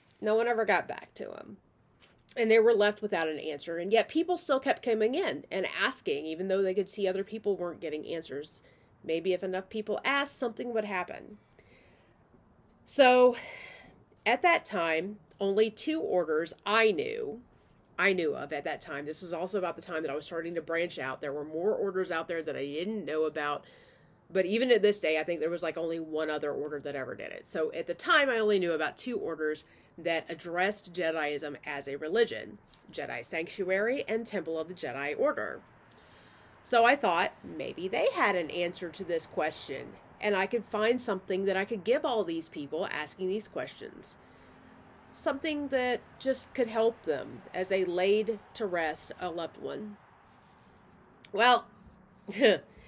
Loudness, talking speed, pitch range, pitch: -30 LUFS, 185 wpm, 165-225 Hz, 190 Hz